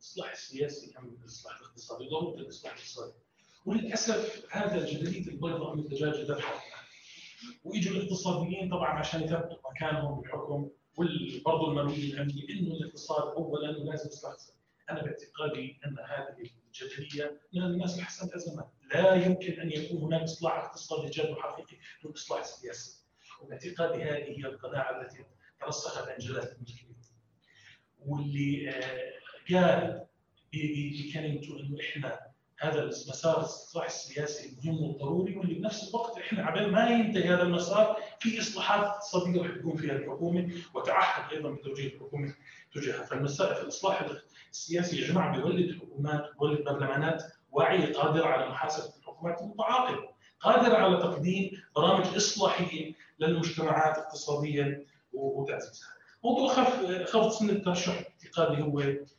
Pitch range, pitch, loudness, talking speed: 145-180 Hz, 160 Hz, -31 LUFS, 125 wpm